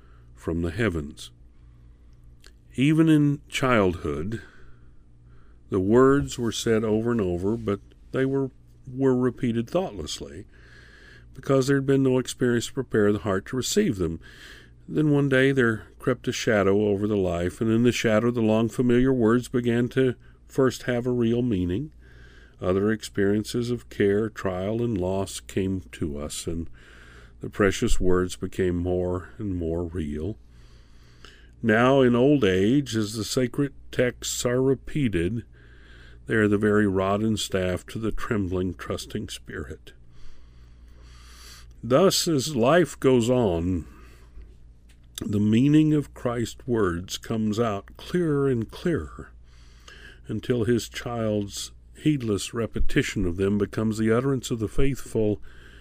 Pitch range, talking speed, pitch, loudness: 75-120 Hz, 135 wpm, 105 Hz, -24 LUFS